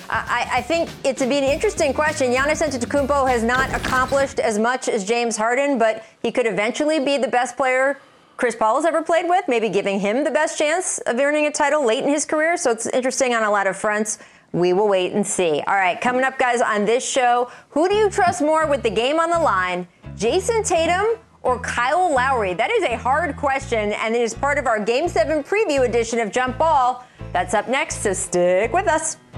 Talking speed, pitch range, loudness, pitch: 225 wpm, 230-310 Hz, -20 LUFS, 265 Hz